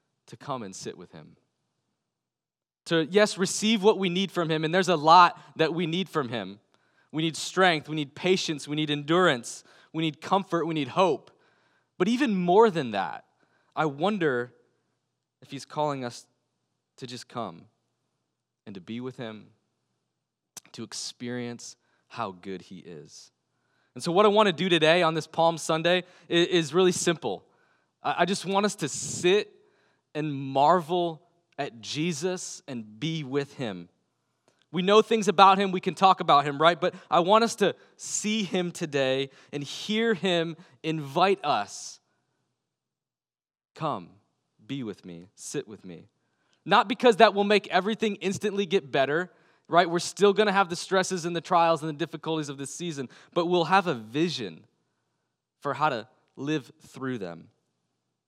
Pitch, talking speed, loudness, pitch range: 170 Hz, 165 wpm, -25 LUFS, 140-190 Hz